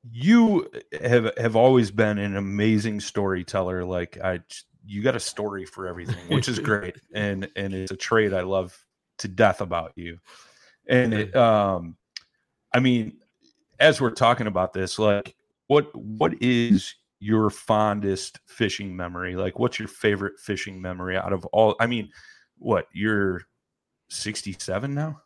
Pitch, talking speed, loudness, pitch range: 105 Hz, 150 wpm, -24 LUFS, 95-115 Hz